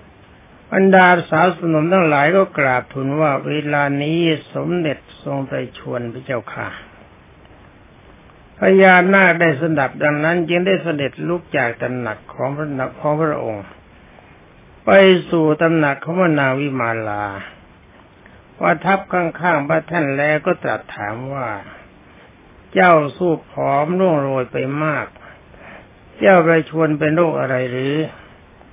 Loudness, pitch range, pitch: -17 LUFS, 130-170 Hz, 155 Hz